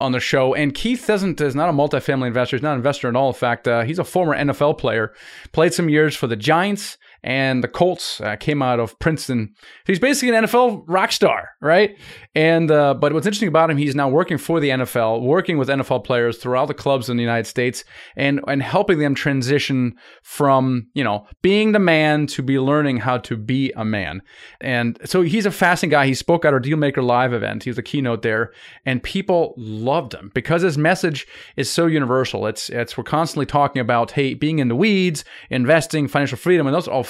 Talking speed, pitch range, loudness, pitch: 220 wpm, 125-165 Hz, -19 LUFS, 140 Hz